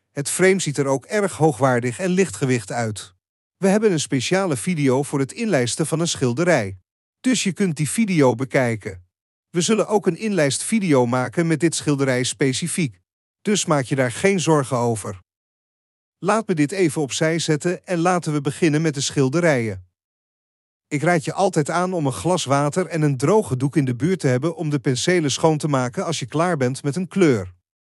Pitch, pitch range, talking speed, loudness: 150 Hz, 125-175 Hz, 190 wpm, -20 LUFS